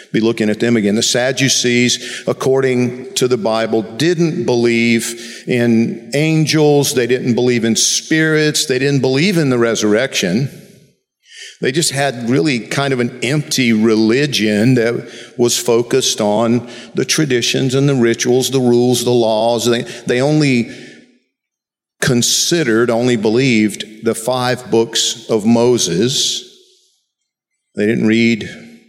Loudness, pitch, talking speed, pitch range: -14 LUFS, 120 Hz, 130 wpm, 115-135 Hz